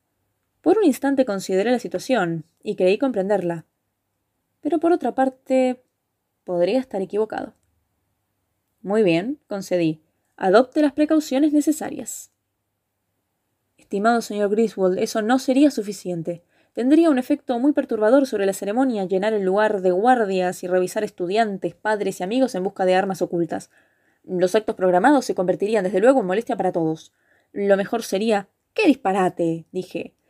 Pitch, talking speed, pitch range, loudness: 200 Hz, 140 wpm, 180-255 Hz, -21 LUFS